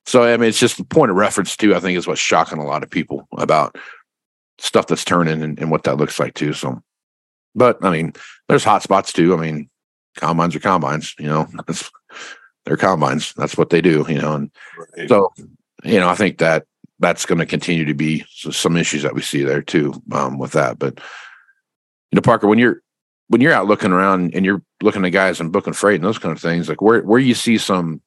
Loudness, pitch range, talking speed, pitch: -17 LUFS, 75-95 Hz, 225 wpm, 85 Hz